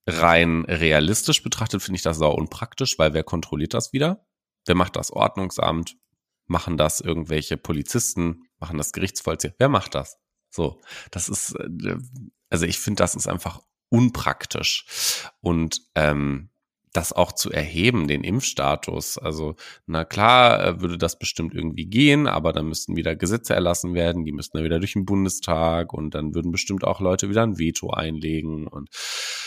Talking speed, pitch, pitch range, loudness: 155 wpm, 85 Hz, 80-105 Hz, -22 LUFS